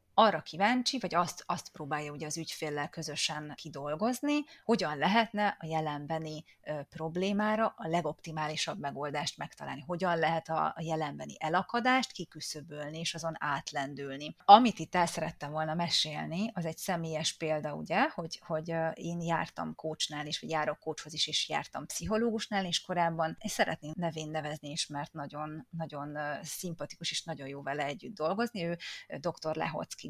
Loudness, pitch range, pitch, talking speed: -33 LUFS, 150-180 Hz, 160 Hz, 150 wpm